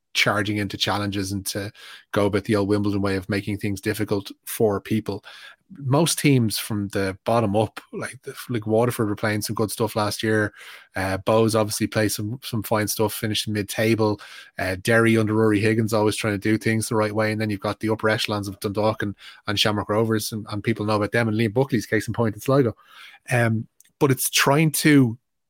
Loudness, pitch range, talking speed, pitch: -22 LUFS, 105-115 Hz, 210 wpm, 110 Hz